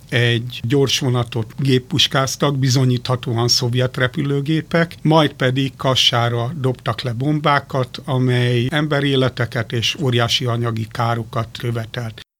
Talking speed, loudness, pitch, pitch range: 100 wpm, -18 LUFS, 125 Hz, 120-140 Hz